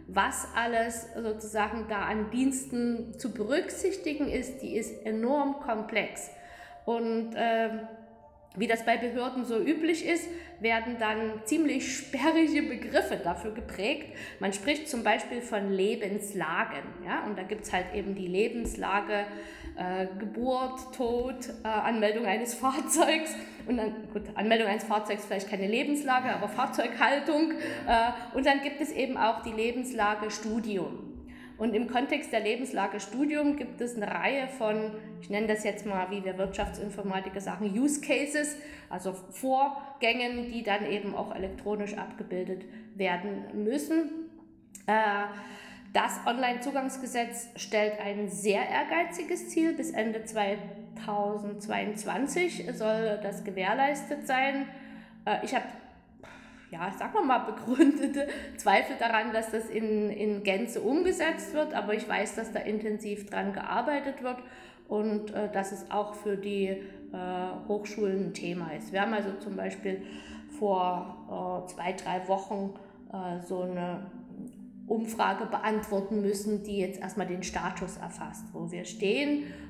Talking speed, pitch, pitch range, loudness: 135 wpm, 220 Hz, 205-255 Hz, -31 LUFS